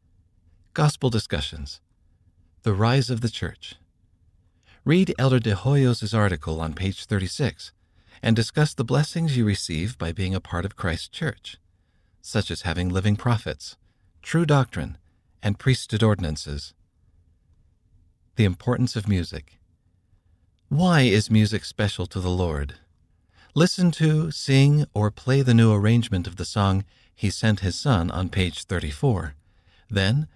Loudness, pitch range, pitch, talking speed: -23 LUFS, 85-115 Hz, 95 Hz, 135 wpm